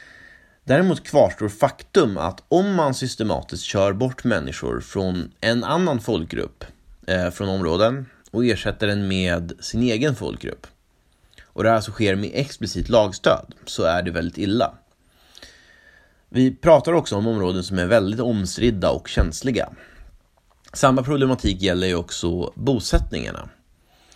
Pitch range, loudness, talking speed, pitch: 95-130 Hz, -21 LUFS, 130 wpm, 110 Hz